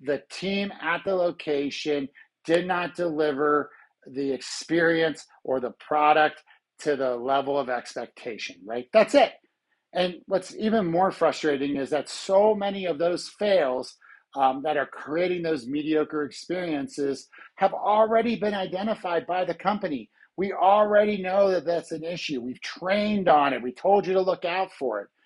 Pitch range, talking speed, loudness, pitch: 140-190 Hz, 155 wpm, -25 LUFS, 165 Hz